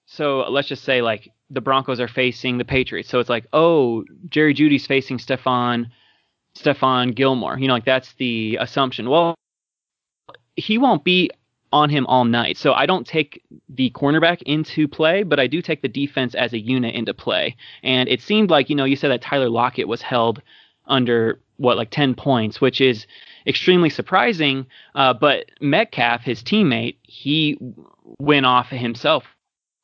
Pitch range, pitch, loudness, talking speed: 125-150 Hz, 130 Hz, -19 LUFS, 170 wpm